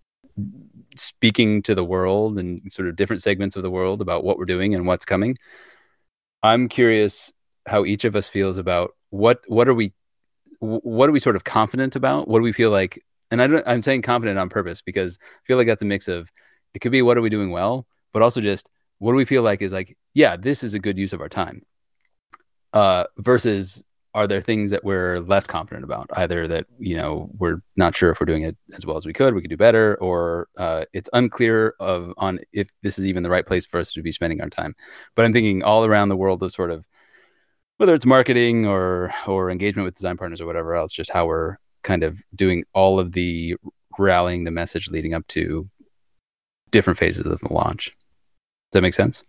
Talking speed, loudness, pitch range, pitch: 220 wpm, -20 LUFS, 90-115 Hz, 100 Hz